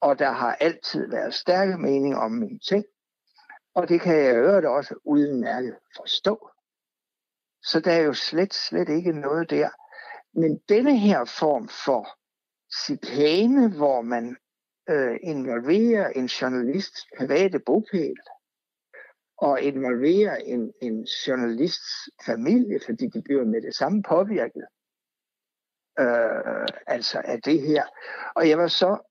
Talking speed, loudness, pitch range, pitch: 135 wpm, -23 LUFS, 140-225 Hz, 175 Hz